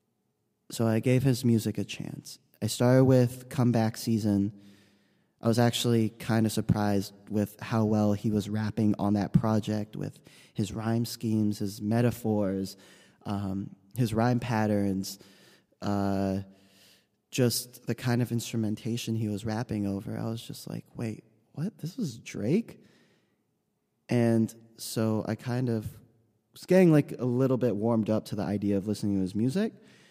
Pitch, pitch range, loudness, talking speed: 110 Hz, 105-120 Hz, -29 LUFS, 155 wpm